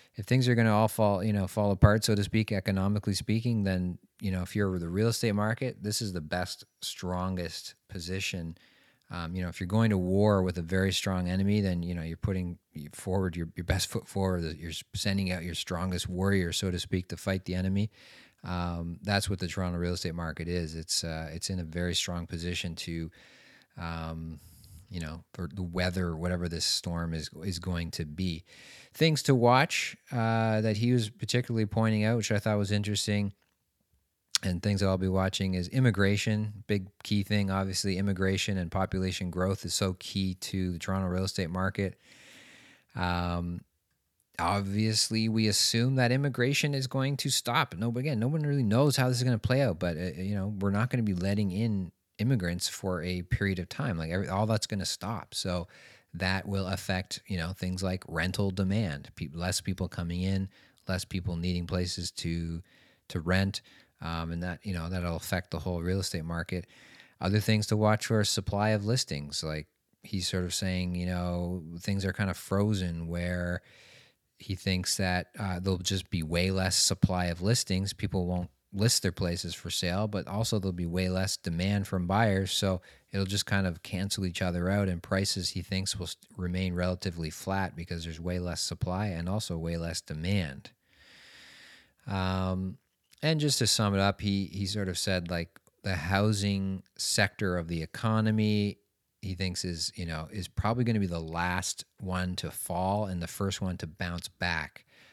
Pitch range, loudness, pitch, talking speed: 90-105 Hz, -30 LUFS, 95 Hz, 195 wpm